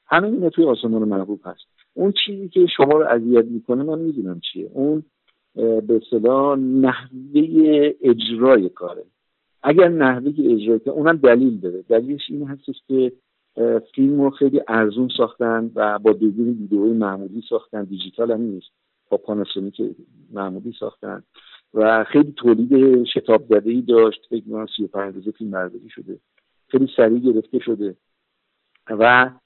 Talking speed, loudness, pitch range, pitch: 135 wpm, -18 LUFS, 110-140 Hz, 120 Hz